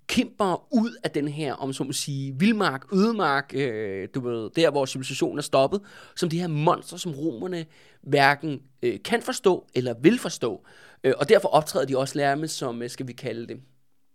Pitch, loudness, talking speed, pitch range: 150 Hz, -25 LUFS, 185 wpm, 135-180 Hz